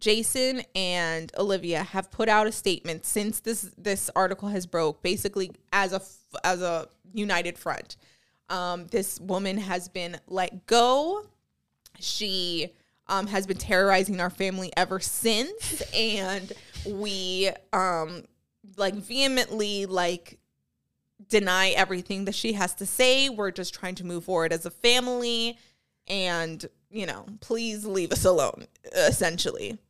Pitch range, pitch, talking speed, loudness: 180-215 Hz, 190 Hz, 135 wpm, -26 LUFS